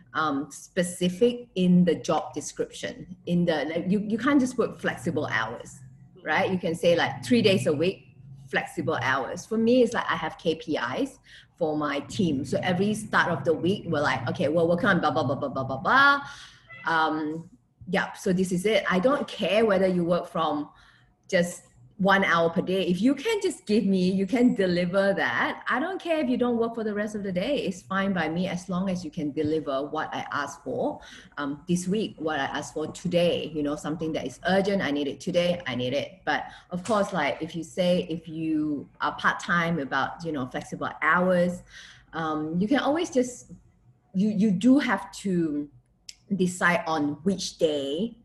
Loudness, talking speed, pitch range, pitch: -26 LUFS, 200 wpm, 155-200 Hz, 175 Hz